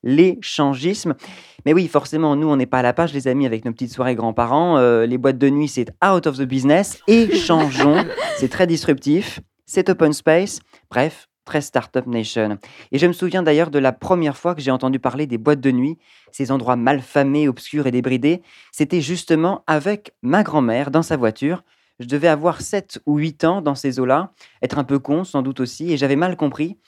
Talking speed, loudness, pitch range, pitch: 205 wpm, -18 LUFS, 130-165 Hz, 145 Hz